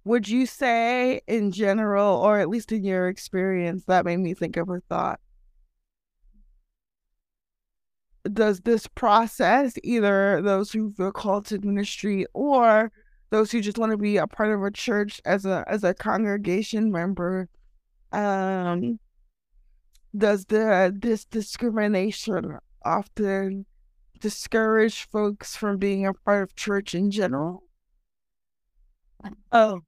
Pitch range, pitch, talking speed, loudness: 190-220 Hz, 205 Hz, 125 wpm, -24 LUFS